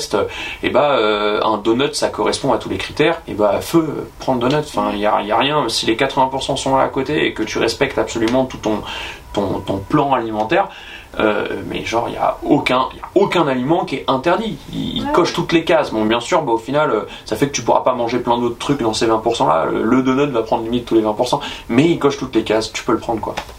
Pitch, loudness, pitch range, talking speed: 120 Hz, -17 LUFS, 110-135 Hz, 245 wpm